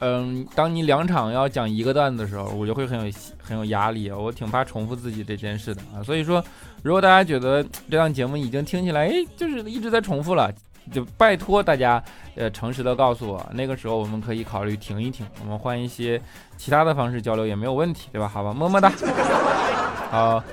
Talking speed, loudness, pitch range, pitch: 325 characters per minute, -23 LUFS, 110-150 Hz, 120 Hz